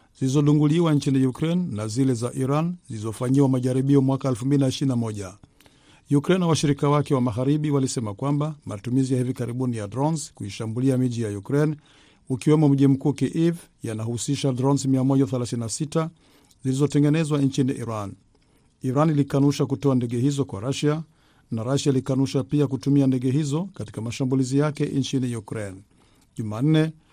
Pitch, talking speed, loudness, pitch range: 135 Hz, 135 wpm, -23 LUFS, 125-145 Hz